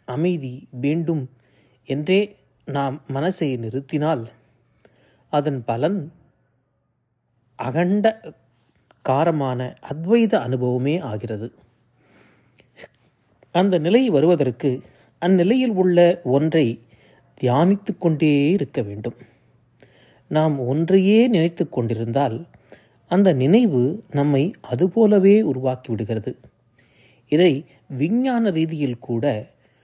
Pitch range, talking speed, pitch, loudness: 125-175 Hz, 70 wpm, 140 Hz, -20 LUFS